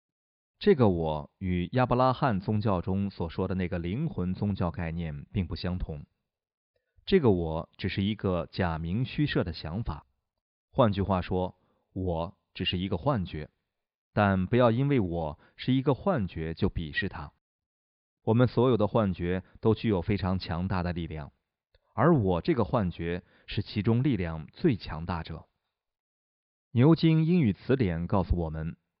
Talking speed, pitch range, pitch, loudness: 225 characters per minute, 85-115 Hz, 95 Hz, -29 LUFS